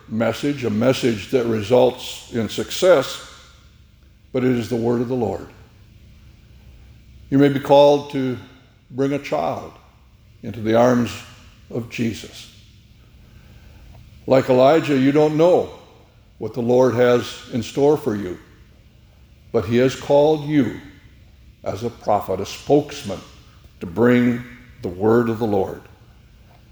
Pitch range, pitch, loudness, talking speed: 110-130 Hz, 120 Hz, -19 LUFS, 130 wpm